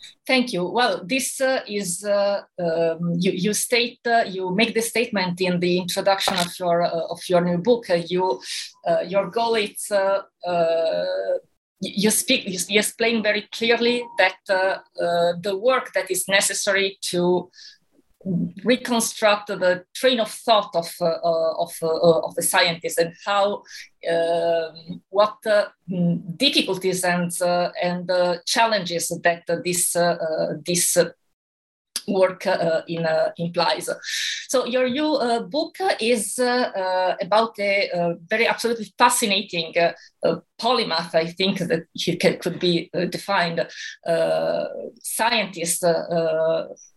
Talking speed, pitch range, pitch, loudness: 135 wpm, 175-225 Hz, 190 Hz, -22 LUFS